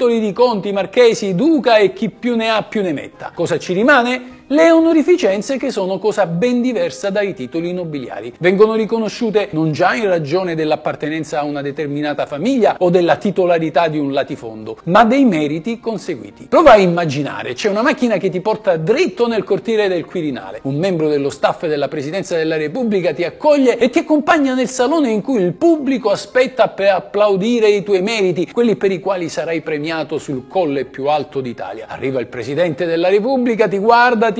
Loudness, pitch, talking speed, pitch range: -16 LUFS, 200 Hz, 180 wpm, 160-235 Hz